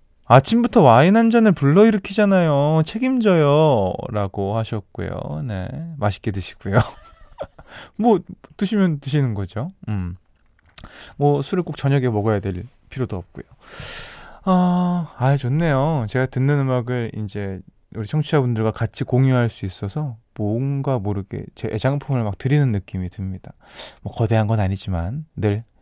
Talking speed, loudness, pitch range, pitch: 285 characters per minute, -20 LUFS, 105-155 Hz, 125 Hz